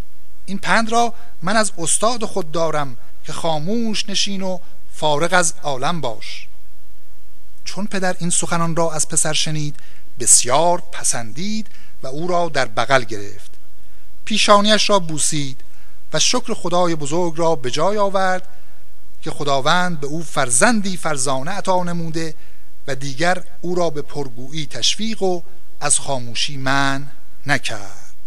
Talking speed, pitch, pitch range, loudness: 135 wpm, 165 Hz, 140-185 Hz, -19 LUFS